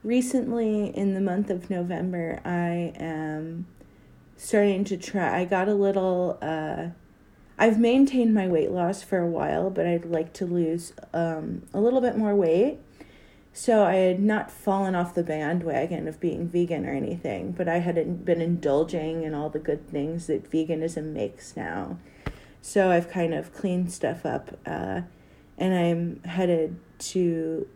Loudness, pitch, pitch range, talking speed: -26 LUFS, 175 Hz, 165-195 Hz, 160 wpm